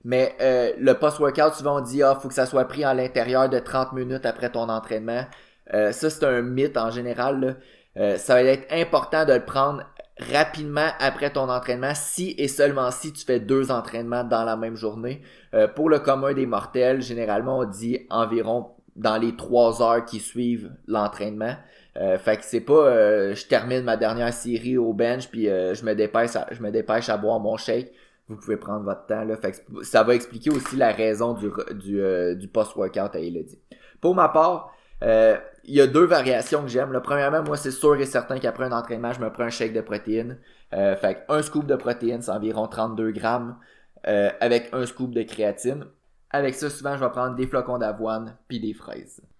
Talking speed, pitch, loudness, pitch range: 205 wpm, 125 Hz, -23 LUFS, 115-140 Hz